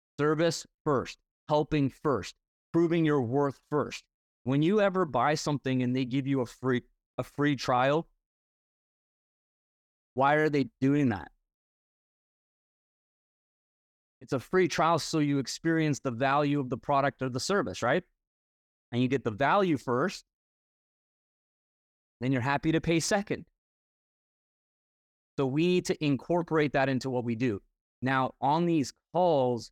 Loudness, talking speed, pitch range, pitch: -29 LUFS, 140 wpm, 125-160 Hz, 140 Hz